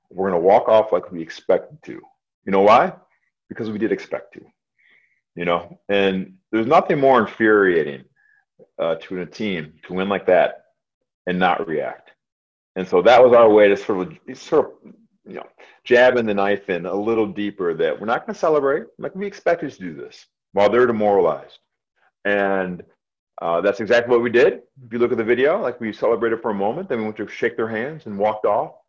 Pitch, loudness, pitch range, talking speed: 110 Hz, -19 LUFS, 100-150 Hz, 200 wpm